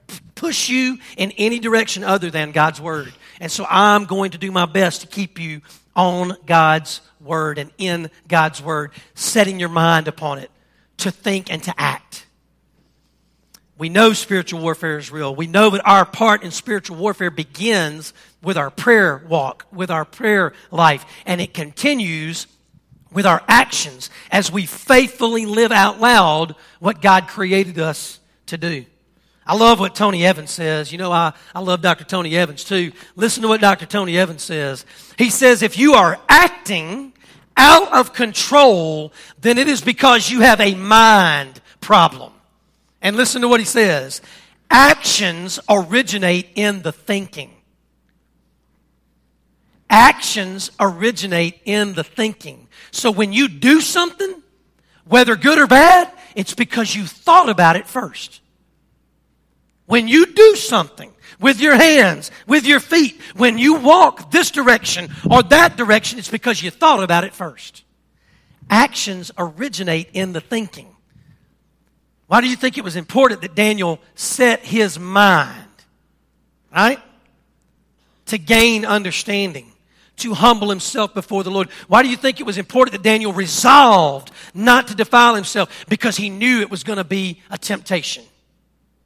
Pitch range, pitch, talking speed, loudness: 170-230 Hz, 195 Hz, 150 wpm, -14 LUFS